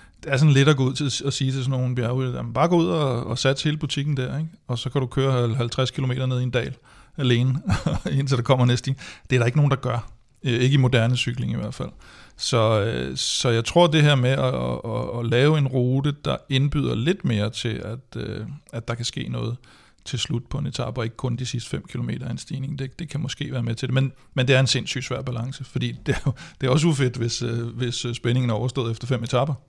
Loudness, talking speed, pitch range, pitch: -23 LUFS, 255 wpm, 120-140 Hz, 130 Hz